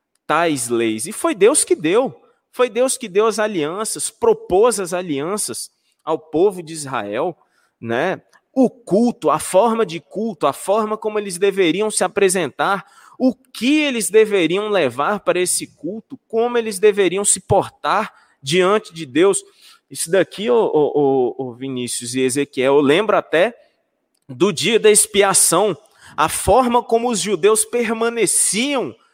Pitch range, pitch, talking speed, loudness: 170-240 Hz, 210 Hz, 140 wpm, -17 LUFS